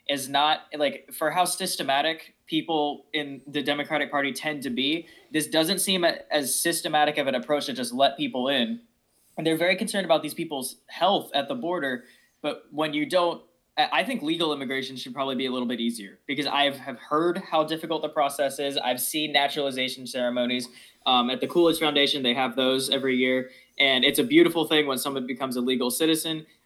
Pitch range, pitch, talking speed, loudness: 130-160 Hz, 145 Hz, 195 wpm, -25 LUFS